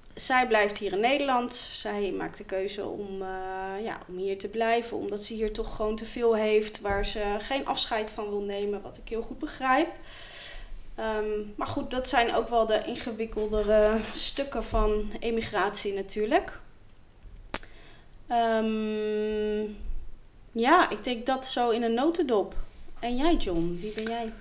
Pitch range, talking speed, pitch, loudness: 210-240 Hz, 155 wpm, 220 Hz, -28 LUFS